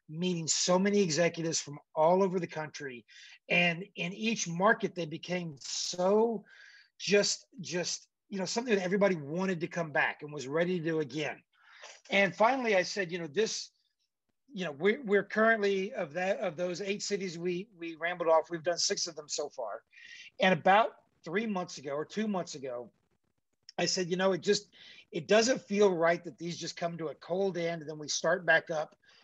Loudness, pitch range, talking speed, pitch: -31 LUFS, 165-200 Hz, 195 wpm, 180 Hz